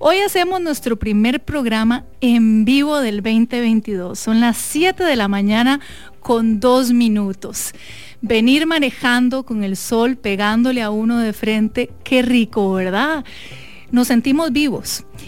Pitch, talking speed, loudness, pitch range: 235 Hz, 135 wpm, -17 LUFS, 220-265 Hz